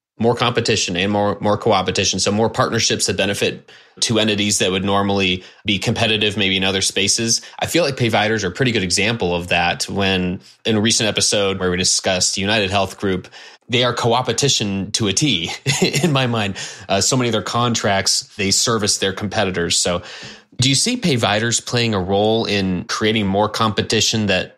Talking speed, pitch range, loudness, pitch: 185 wpm, 95-115 Hz, -17 LUFS, 105 Hz